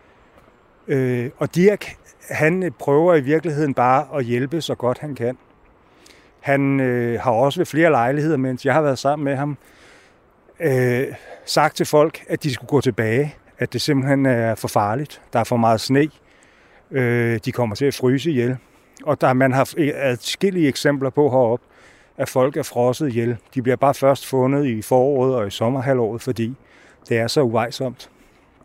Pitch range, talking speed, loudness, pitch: 125-145 Hz, 180 wpm, -20 LUFS, 135 Hz